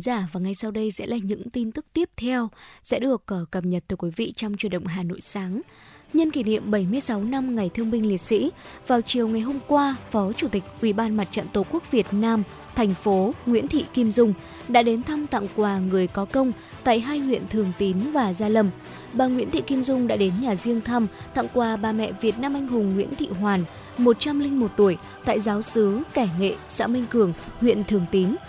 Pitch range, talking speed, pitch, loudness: 200-250 Hz, 225 wpm, 225 Hz, -24 LUFS